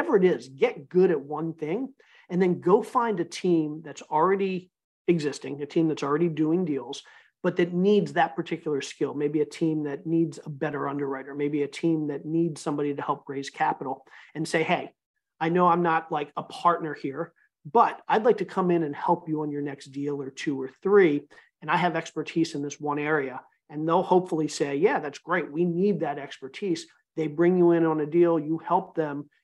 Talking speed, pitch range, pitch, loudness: 210 wpm, 145-175 Hz, 160 Hz, -26 LUFS